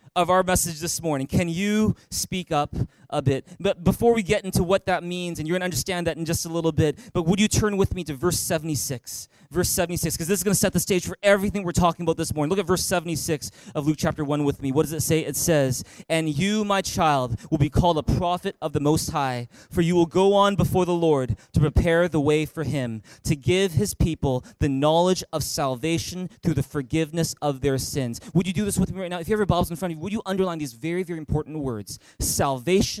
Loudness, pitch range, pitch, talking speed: -24 LUFS, 150-185 Hz, 165 Hz, 255 wpm